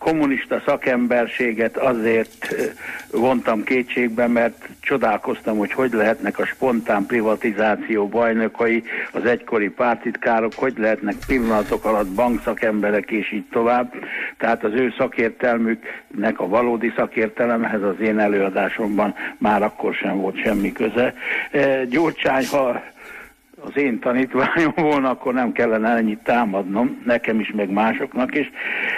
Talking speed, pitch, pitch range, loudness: 120 wpm, 115 Hz, 110-125 Hz, -20 LUFS